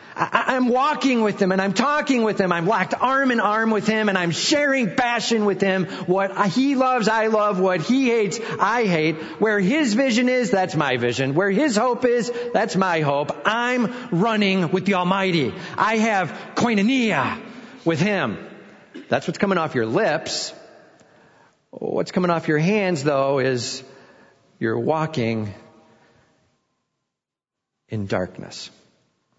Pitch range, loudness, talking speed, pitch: 170-240 Hz, -21 LUFS, 150 wpm, 200 Hz